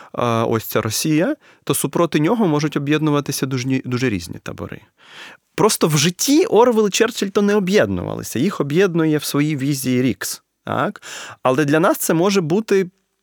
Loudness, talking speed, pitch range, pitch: -18 LUFS, 145 wpm, 145-195 Hz, 155 Hz